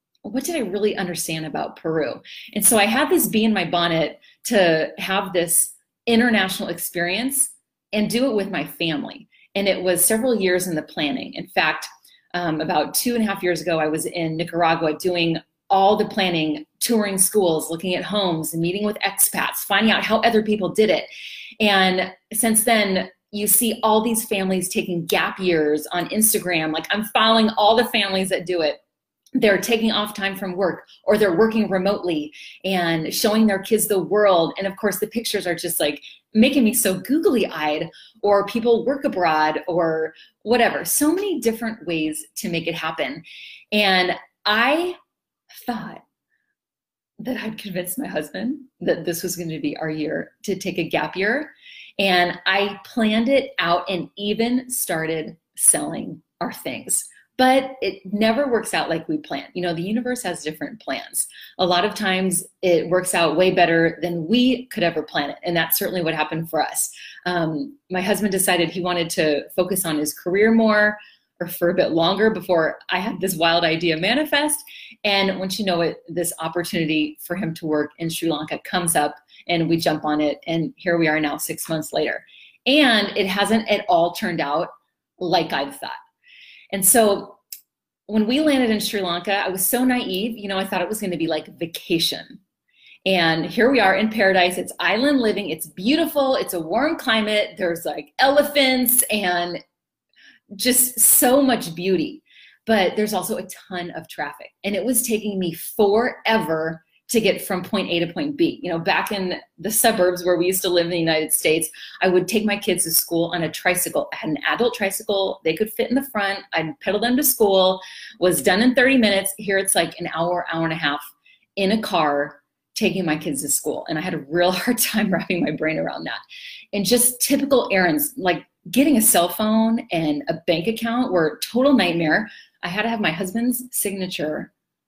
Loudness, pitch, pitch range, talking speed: -20 LUFS, 195 Hz, 170-225 Hz, 190 wpm